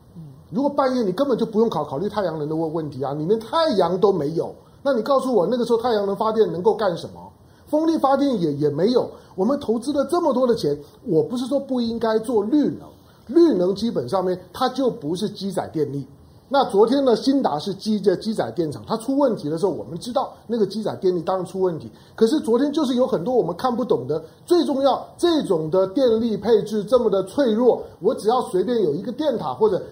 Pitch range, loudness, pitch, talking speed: 185-270 Hz, -21 LUFS, 225 Hz, 335 characters per minute